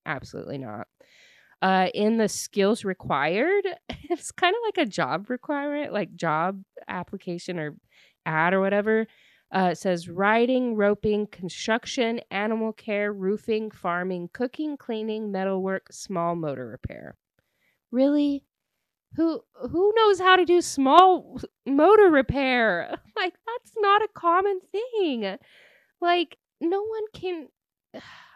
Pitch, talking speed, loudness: 225 Hz, 120 wpm, -24 LUFS